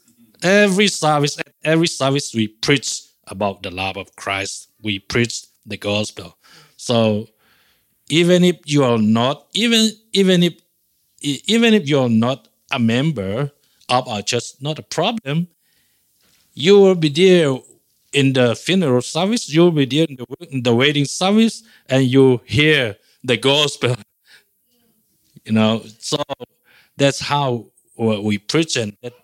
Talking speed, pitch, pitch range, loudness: 135 wpm, 140 Hz, 115-165 Hz, -17 LUFS